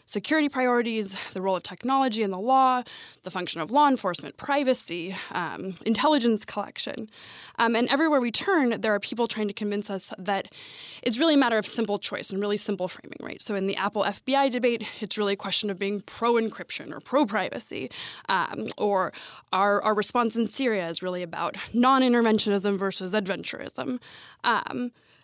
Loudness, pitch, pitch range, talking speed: -26 LUFS, 215 Hz, 195-250 Hz, 180 wpm